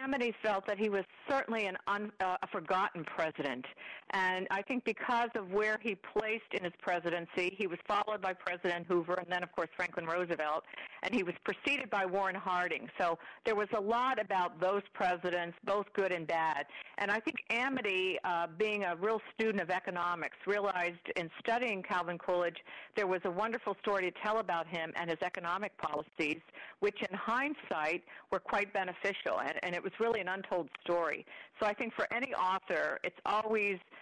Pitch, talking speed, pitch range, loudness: 195 Hz, 185 wpm, 180-215 Hz, -35 LUFS